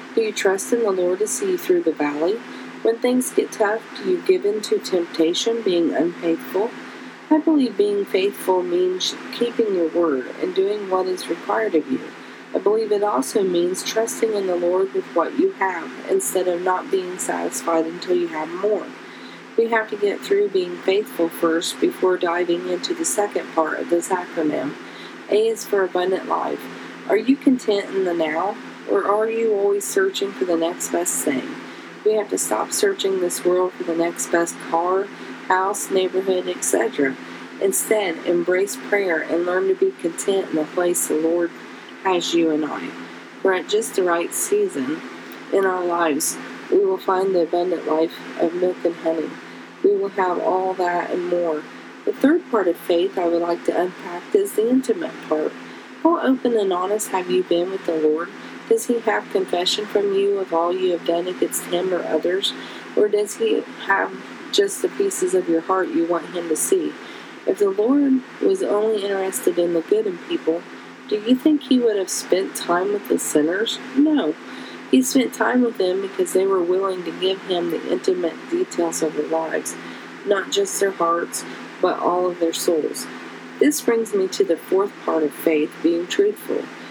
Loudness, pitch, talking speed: -21 LUFS, 195 Hz, 190 wpm